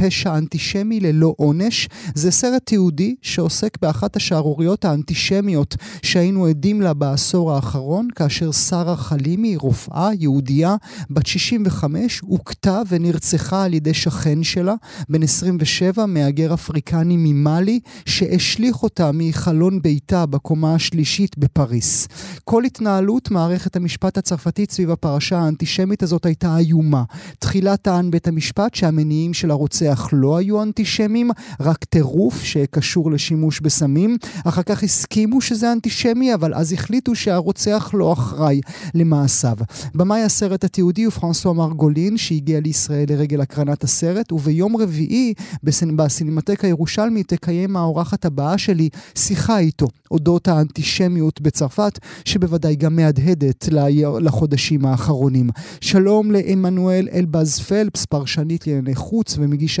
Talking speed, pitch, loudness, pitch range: 120 wpm, 170 Hz, -18 LUFS, 155-195 Hz